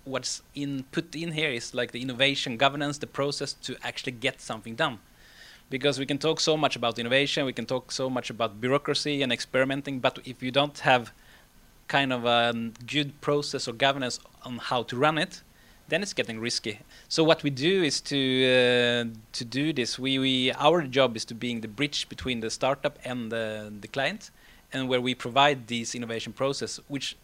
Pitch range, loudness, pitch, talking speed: 120-140 Hz, -27 LUFS, 130 Hz, 195 wpm